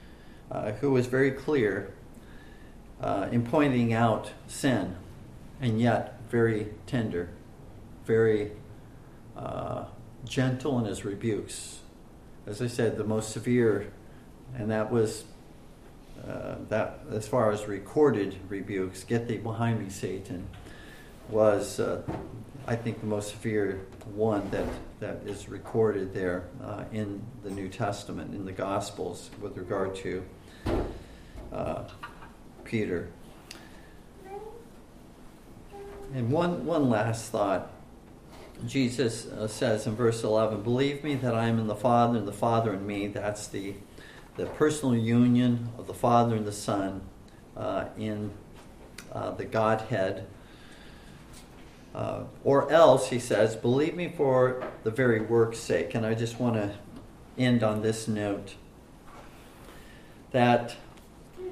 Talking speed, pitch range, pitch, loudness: 125 wpm, 105-125 Hz, 110 Hz, -29 LUFS